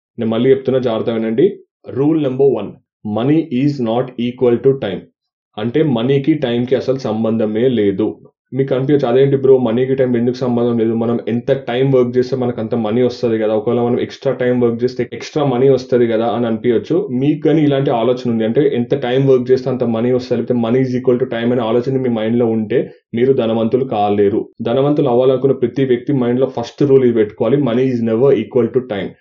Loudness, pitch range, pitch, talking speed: -15 LUFS, 115-135 Hz, 125 Hz, 195 wpm